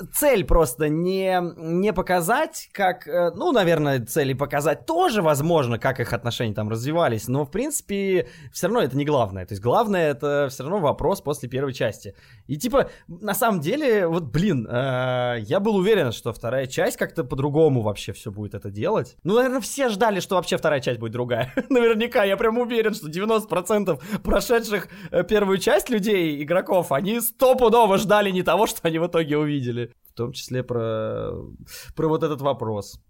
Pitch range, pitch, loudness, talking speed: 130-200 Hz, 165 Hz, -22 LUFS, 170 wpm